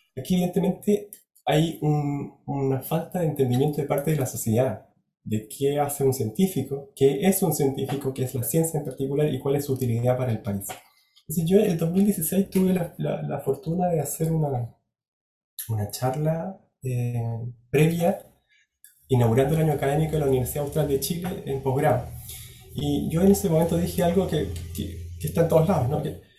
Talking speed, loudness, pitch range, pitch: 180 wpm, -25 LUFS, 125-165 Hz, 140 Hz